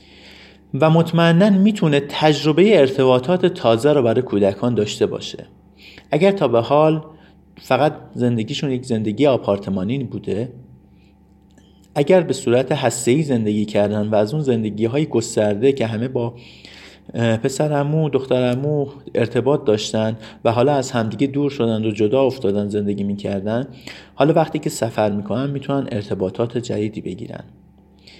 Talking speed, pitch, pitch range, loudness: 135 wpm, 120 Hz, 105-145 Hz, -18 LUFS